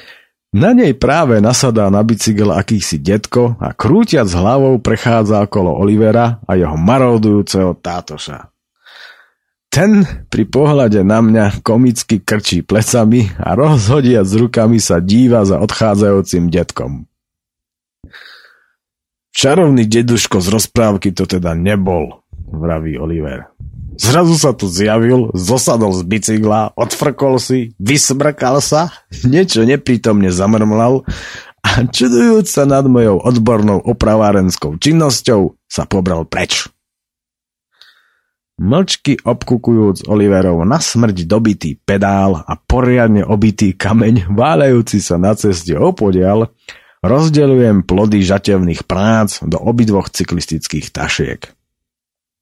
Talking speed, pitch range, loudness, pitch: 105 wpm, 95-120 Hz, -12 LUFS, 110 Hz